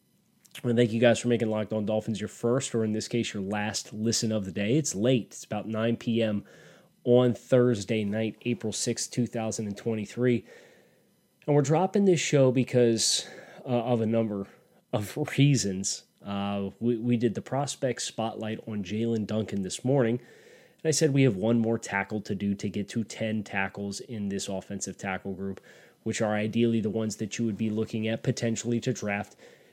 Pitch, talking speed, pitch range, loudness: 115 Hz, 190 wpm, 105-120 Hz, -28 LUFS